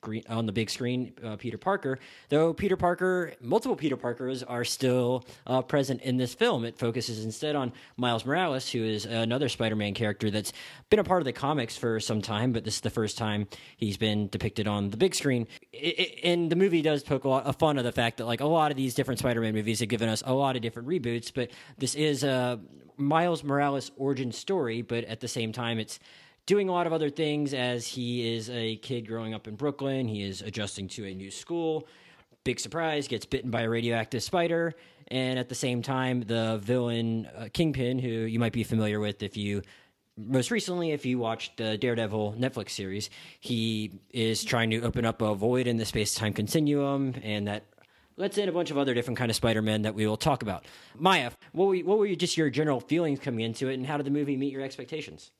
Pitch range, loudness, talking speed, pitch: 110-145 Hz, -29 LUFS, 225 wpm, 125 Hz